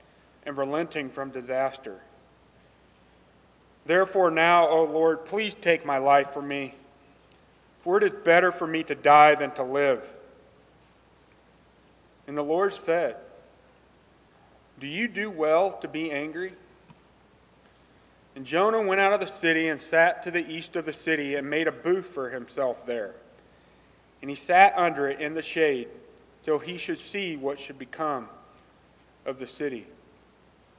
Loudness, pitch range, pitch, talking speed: -25 LUFS, 140-180 Hz, 160 Hz, 150 wpm